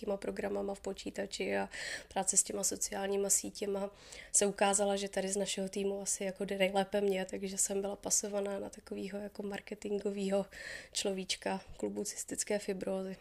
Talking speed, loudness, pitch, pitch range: 155 wpm, -35 LUFS, 200 Hz, 195-200 Hz